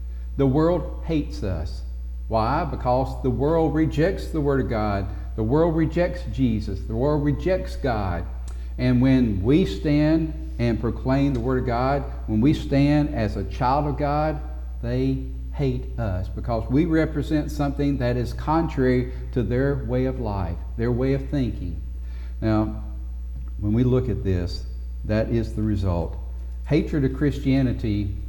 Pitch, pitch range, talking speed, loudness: 120 Hz, 95-140 Hz, 150 wpm, -24 LUFS